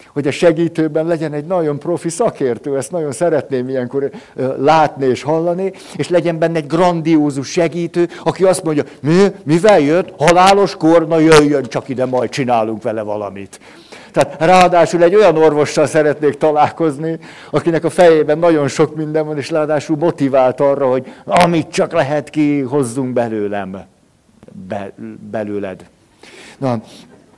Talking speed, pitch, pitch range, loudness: 140 wpm, 155 Hz, 135-170 Hz, -14 LUFS